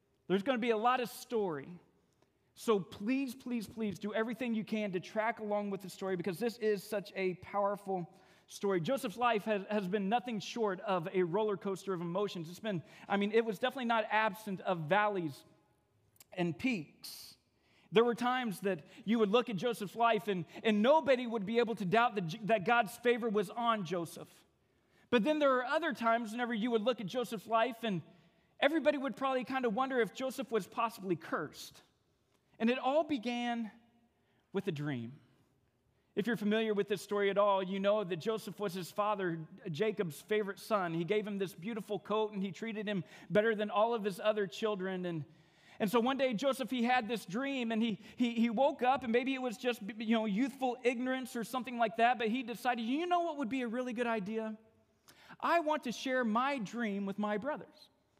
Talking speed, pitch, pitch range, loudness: 205 wpm, 220 Hz, 195-240 Hz, -35 LUFS